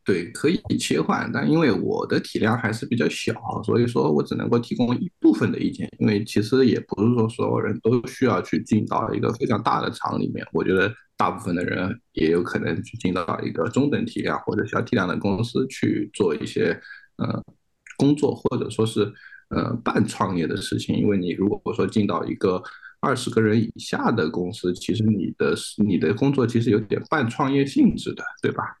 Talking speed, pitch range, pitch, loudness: 300 characters per minute, 105-130 Hz, 115 Hz, -23 LUFS